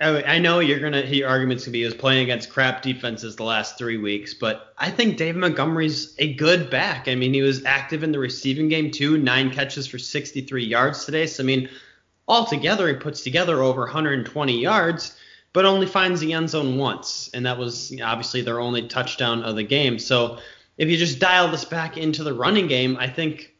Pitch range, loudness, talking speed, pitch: 125-160 Hz, -21 LUFS, 210 wpm, 135 Hz